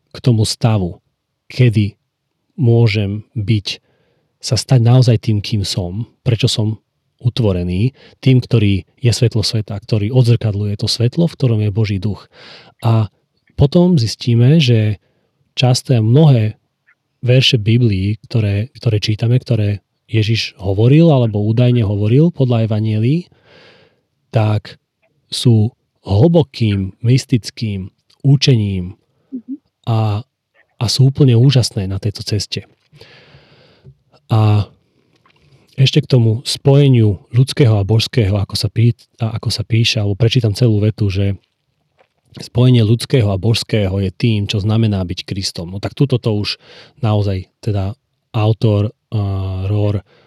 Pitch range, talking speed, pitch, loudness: 105-130 Hz, 120 wpm, 115 Hz, -15 LUFS